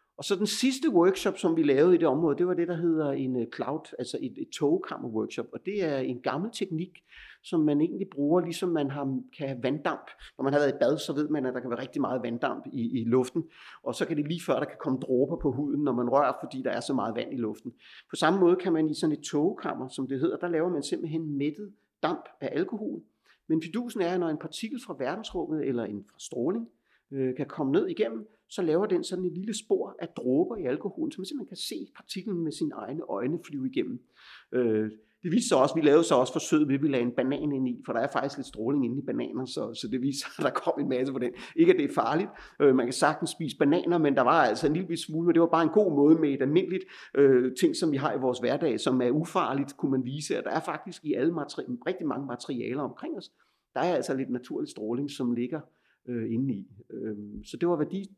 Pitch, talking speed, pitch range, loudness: 155 Hz, 250 wpm, 130-185 Hz, -28 LUFS